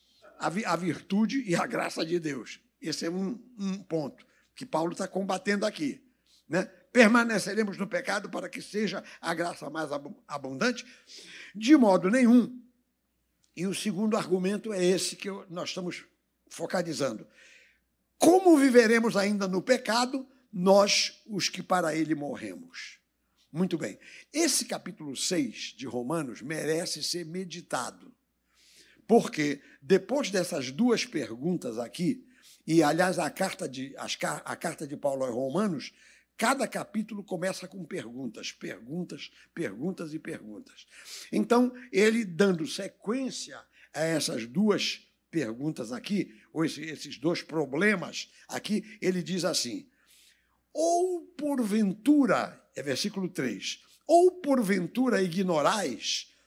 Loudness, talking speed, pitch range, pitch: -28 LUFS, 120 wpm, 170-235 Hz, 190 Hz